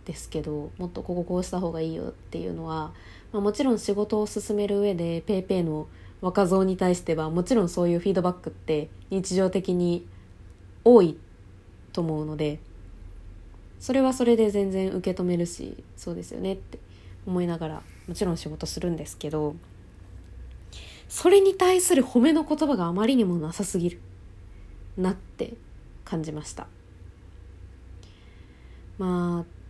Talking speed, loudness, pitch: 310 characters per minute, -26 LUFS, 170 Hz